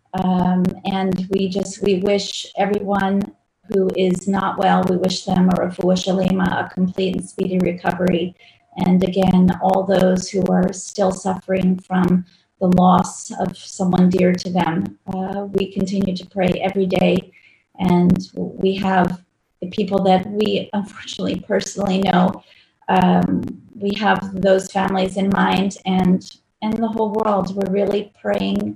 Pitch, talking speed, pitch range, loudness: 190 Hz, 145 wpm, 185-195 Hz, -19 LUFS